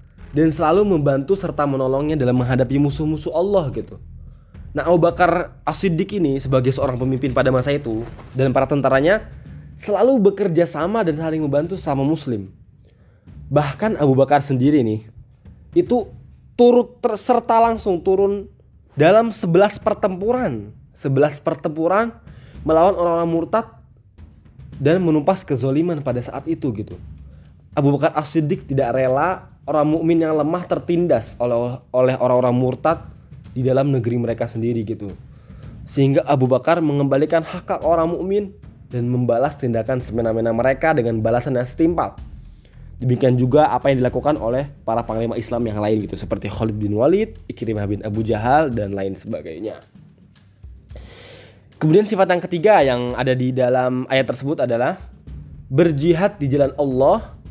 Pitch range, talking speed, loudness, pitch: 120-165 Hz, 140 wpm, -19 LUFS, 135 Hz